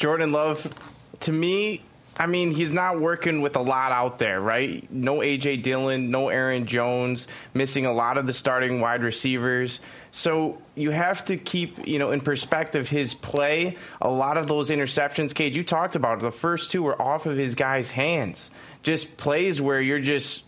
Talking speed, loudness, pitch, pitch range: 190 wpm, -24 LUFS, 145 Hz, 130-160 Hz